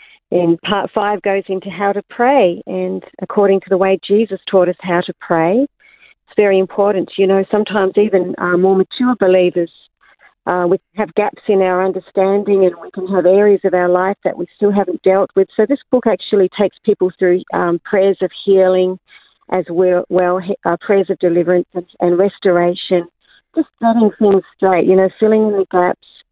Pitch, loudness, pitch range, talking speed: 190 Hz, -15 LUFS, 180-205 Hz, 185 wpm